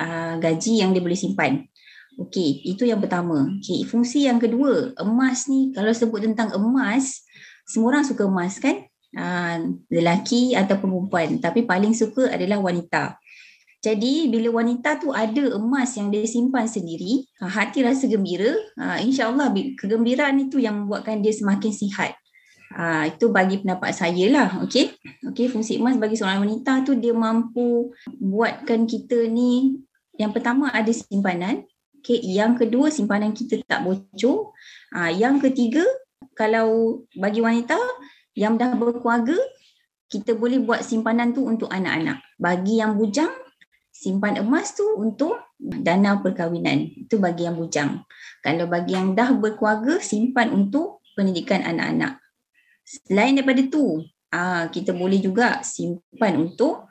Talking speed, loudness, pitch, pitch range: 140 wpm, -22 LUFS, 230 Hz, 195-260 Hz